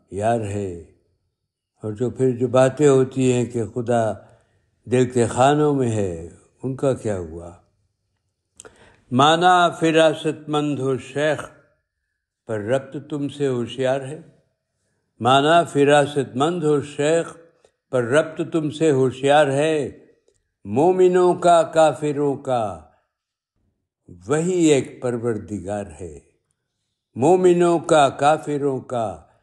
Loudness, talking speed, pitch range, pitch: -19 LUFS, 110 wpm, 110-150 Hz, 130 Hz